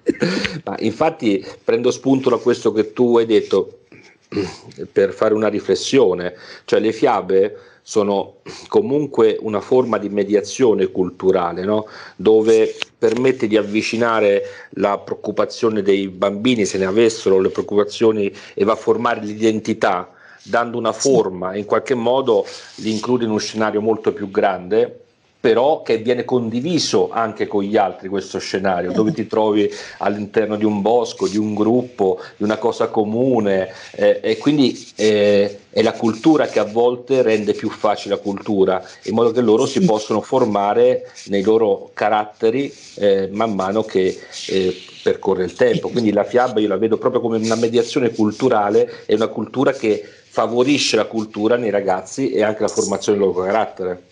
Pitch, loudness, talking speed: 115 Hz, -18 LUFS, 155 wpm